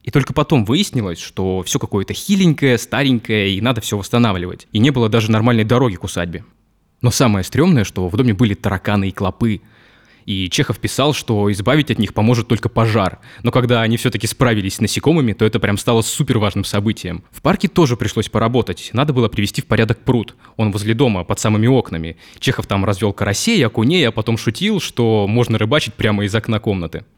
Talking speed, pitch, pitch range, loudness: 190 wpm, 115 Hz, 105-125 Hz, -17 LUFS